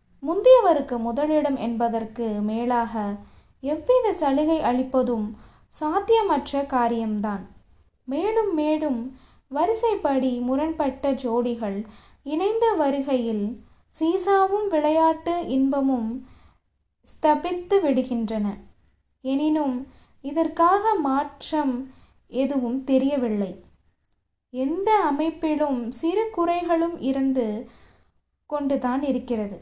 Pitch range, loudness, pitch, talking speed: 240-320 Hz, -24 LUFS, 275 Hz, 65 wpm